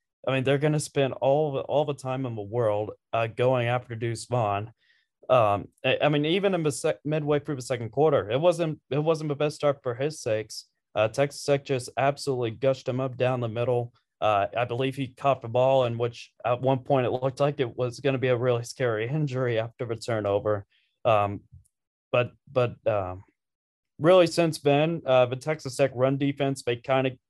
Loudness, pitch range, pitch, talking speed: -26 LUFS, 120-145 Hz, 130 Hz, 210 wpm